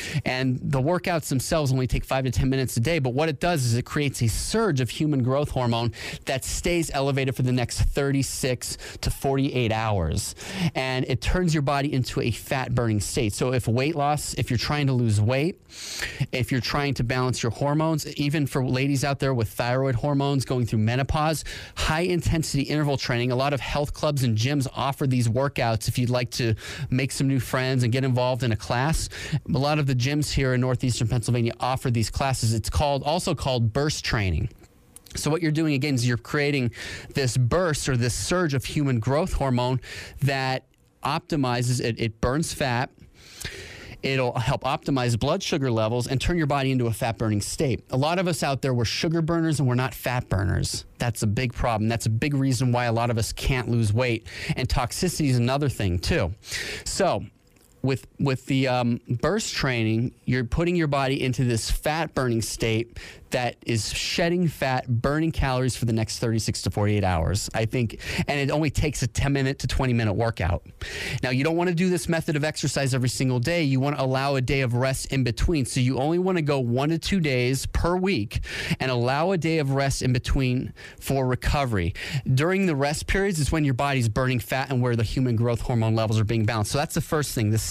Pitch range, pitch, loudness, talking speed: 120-145 Hz, 130 Hz, -25 LUFS, 210 wpm